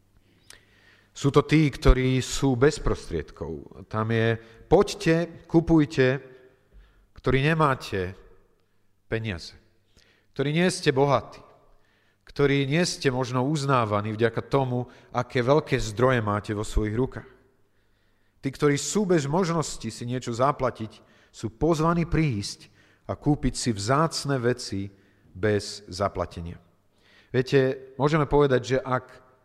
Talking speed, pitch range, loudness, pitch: 110 wpm, 105-140 Hz, -25 LUFS, 125 Hz